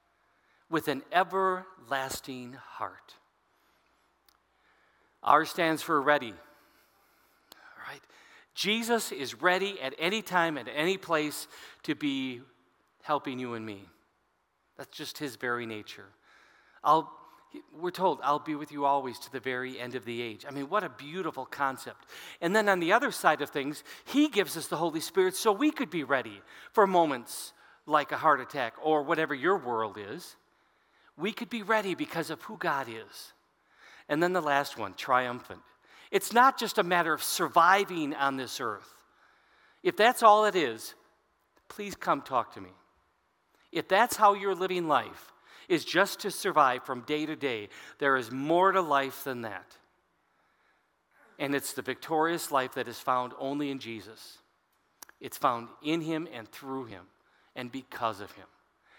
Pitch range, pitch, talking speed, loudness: 130-185 Hz, 150 Hz, 160 wpm, -29 LUFS